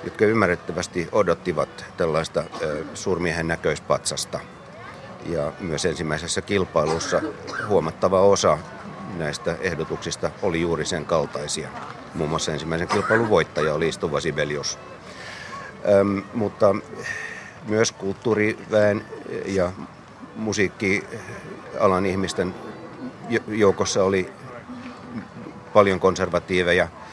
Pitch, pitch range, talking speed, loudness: 90 Hz, 80-100 Hz, 80 wpm, -23 LUFS